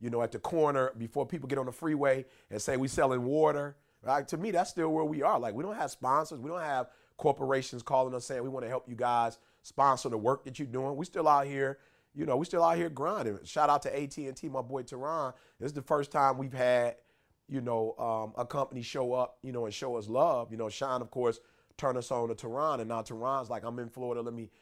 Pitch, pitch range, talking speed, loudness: 135 Hz, 120-145 Hz, 260 wpm, -32 LUFS